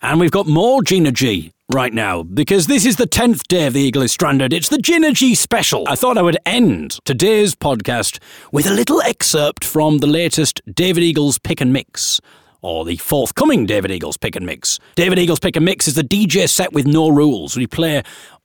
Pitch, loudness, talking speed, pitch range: 160 Hz, -15 LUFS, 210 wpm, 135-190 Hz